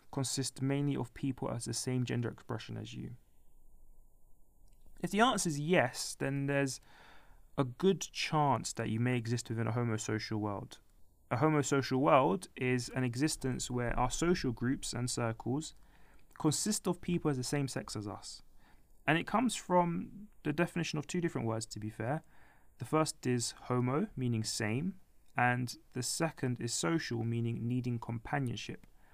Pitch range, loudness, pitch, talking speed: 115-150 Hz, -34 LUFS, 125 Hz, 160 wpm